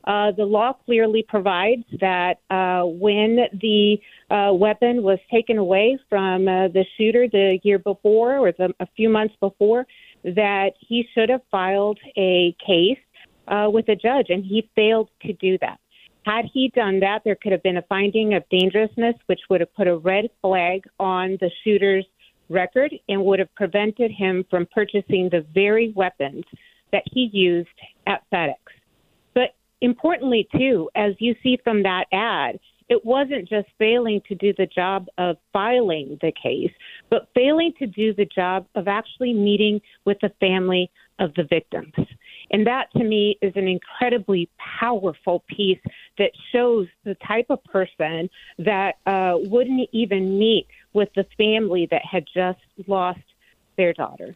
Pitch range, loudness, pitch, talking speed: 185-225 Hz, -21 LUFS, 205 Hz, 160 wpm